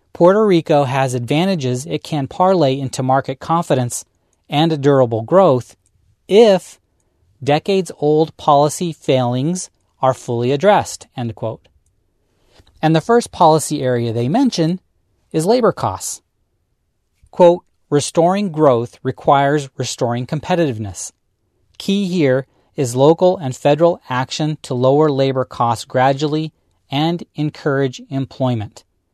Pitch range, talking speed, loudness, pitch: 125-160 Hz, 110 wpm, -16 LUFS, 140 Hz